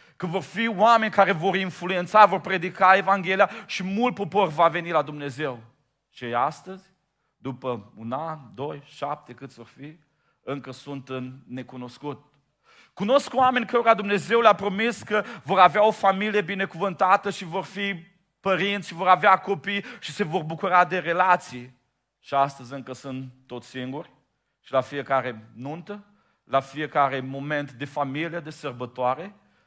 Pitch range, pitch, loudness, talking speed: 135-195 Hz, 170 Hz, -23 LUFS, 150 wpm